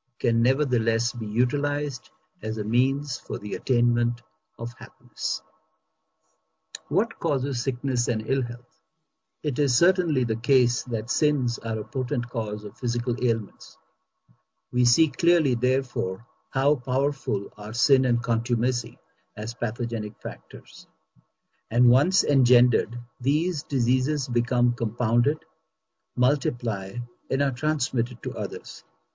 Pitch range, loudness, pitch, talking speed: 120-135 Hz, -25 LUFS, 125 Hz, 120 wpm